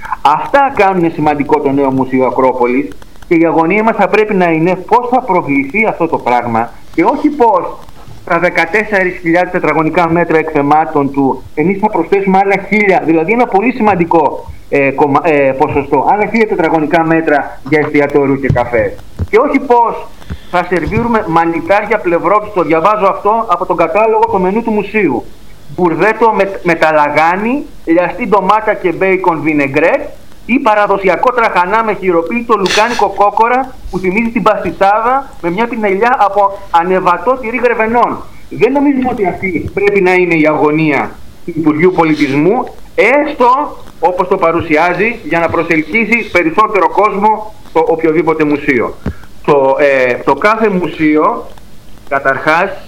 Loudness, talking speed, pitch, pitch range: -11 LUFS, 140 wpm, 180 Hz, 160-215 Hz